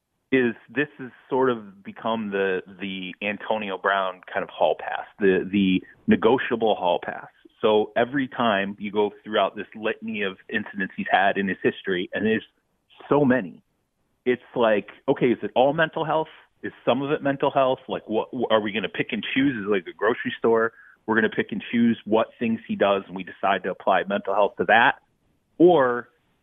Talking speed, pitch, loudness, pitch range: 200 wpm, 115 Hz, -24 LUFS, 100-130 Hz